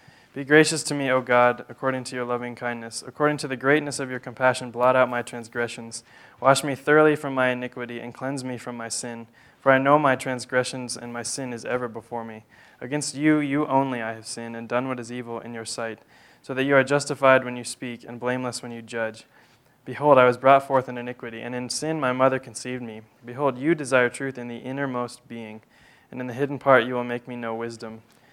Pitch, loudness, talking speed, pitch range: 125 Hz, -24 LUFS, 225 wpm, 120-135 Hz